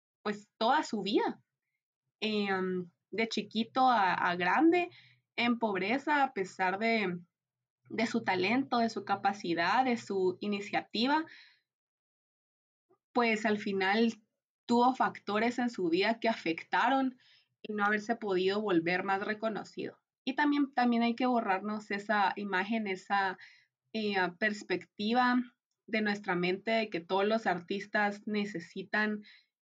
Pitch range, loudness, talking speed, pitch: 190-235 Hz, -31 LUFS, 125 wpm, 210 Hz